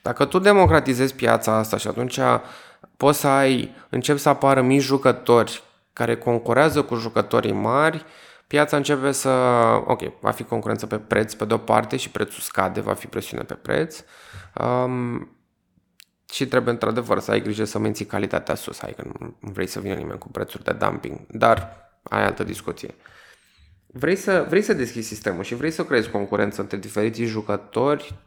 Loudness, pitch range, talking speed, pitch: -22 LUFS, 110-140 Hz, 170 wpm, 120 Hz